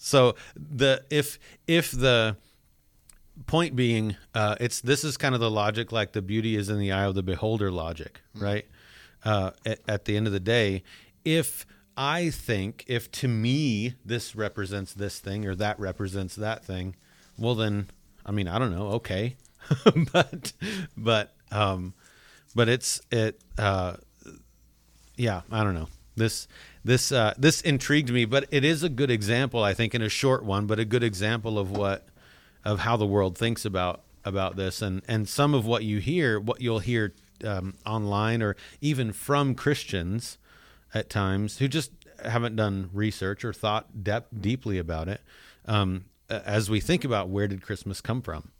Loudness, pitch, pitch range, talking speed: -27 LUFS, 110 Hz, 100-125 Hz, 175 wpm